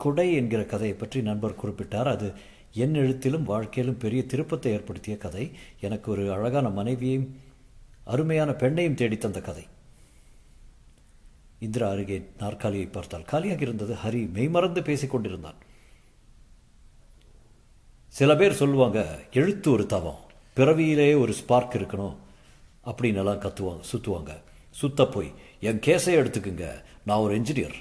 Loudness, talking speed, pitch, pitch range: -26 LUFS, 110 wpm, 115 Hz, 100-130 Hz